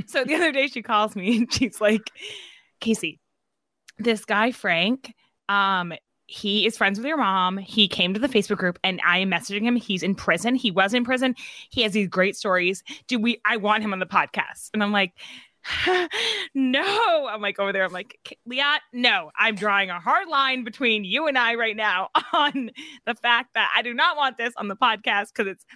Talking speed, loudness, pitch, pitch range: 205 wpm, -22 LUFS, 225 Hz, 200-265 Hz